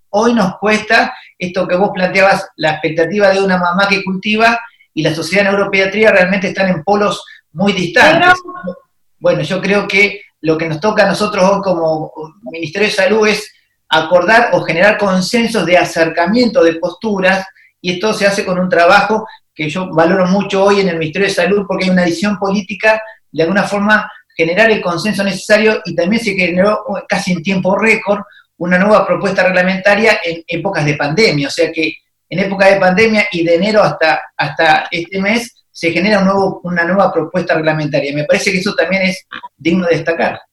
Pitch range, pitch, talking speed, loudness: 170-205 Hz, 190 Hz, 185 wpm, -12 LUFS